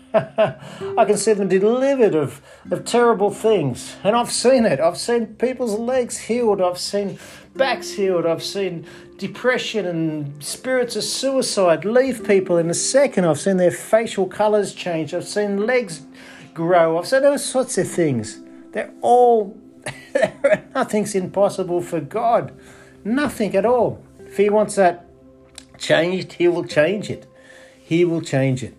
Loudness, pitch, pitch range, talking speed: -19 LUFS, 195 Hz, 170-225 Hz, 150 wpm